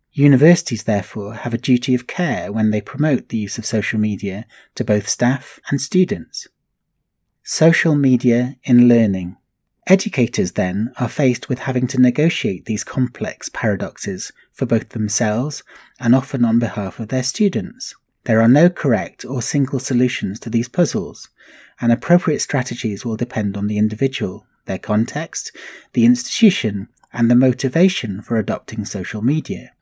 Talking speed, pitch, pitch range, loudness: 150 wpm, 125 Hz, 110-140 Hz, -18 LUFS